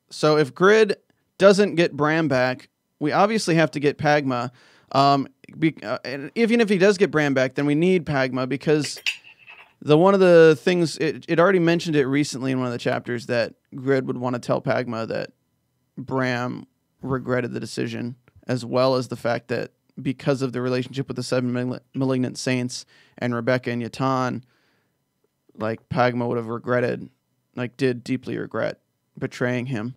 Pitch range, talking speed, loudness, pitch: 125-150 Hz, 175 wpm, -22 LUFS, 130 Hz